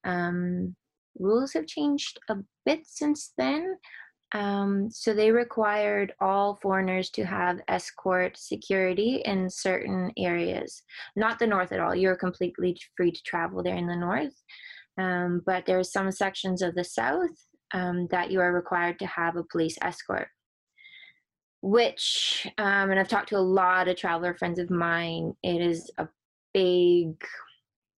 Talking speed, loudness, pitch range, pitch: 155 wpm, -27 LUFS, 180-215 Hz, 190 Hz